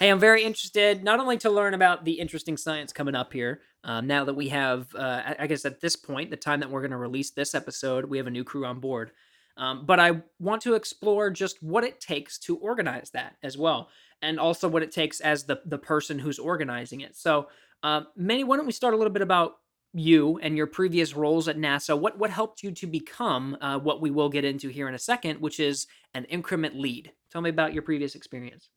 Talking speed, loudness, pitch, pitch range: 240 wpm, -26 LUFS, 155 Hz, 140-185 Hz